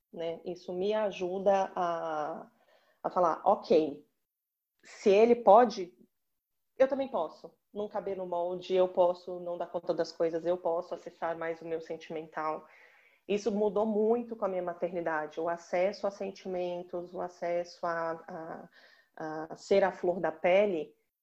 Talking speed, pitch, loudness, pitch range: 150 wpm, 180 Hz, -31 LUFS, 170-200 Hz